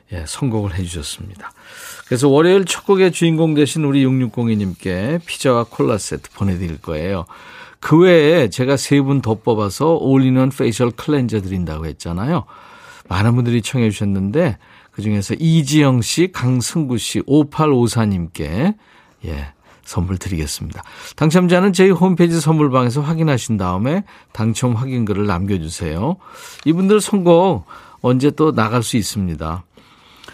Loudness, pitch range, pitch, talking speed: -16 LUFS, 100-155 Hz, 125 Hz, 300 characters per minute